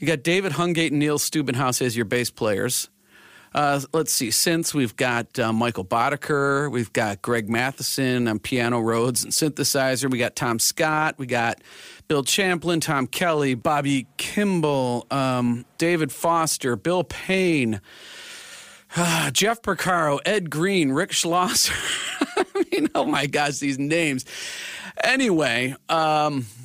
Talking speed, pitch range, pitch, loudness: 135 wpm, 125-165 Hz, 145 Hz, -22 LUFS